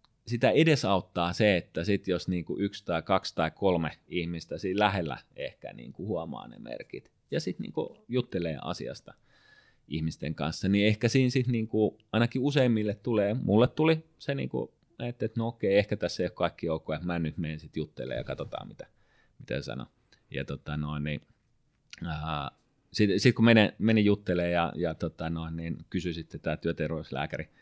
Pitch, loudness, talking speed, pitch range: 95 Hz, -29 LUFS, 170 wpm, 80-115 Hz